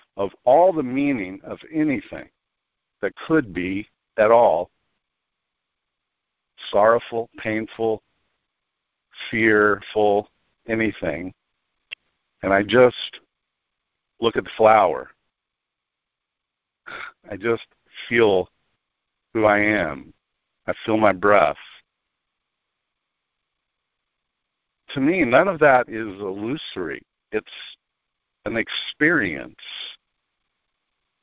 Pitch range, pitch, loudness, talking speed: 105-125 Hz, 110 Hz, -20 LUFS, 80 wpm